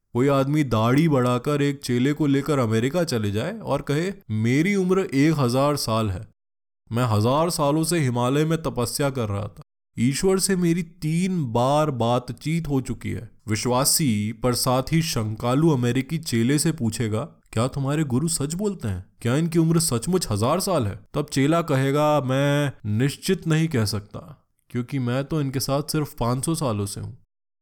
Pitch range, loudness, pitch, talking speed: 115-155 Hz, -23 LUFS, 135 Hz, 170 wpm